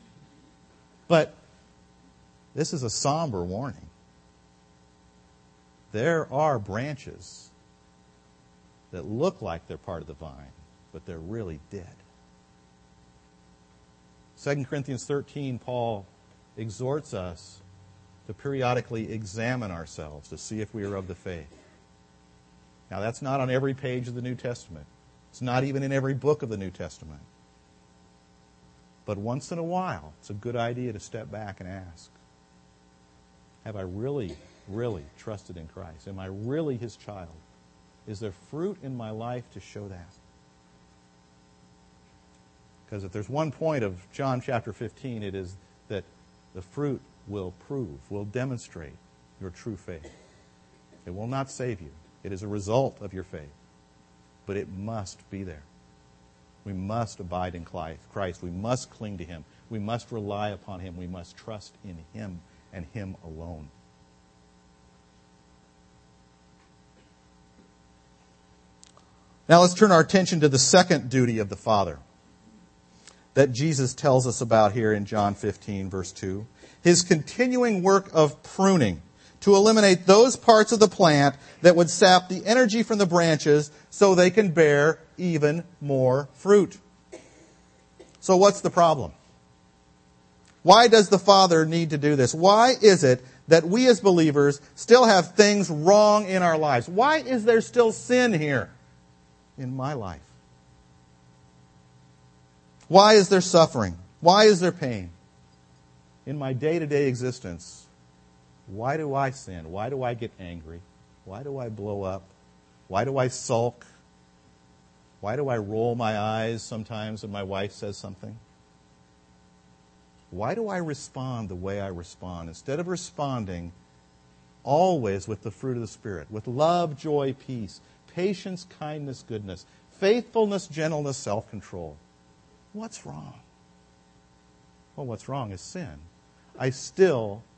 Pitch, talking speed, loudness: 100 Hz, 140 wpm, -23 LUFS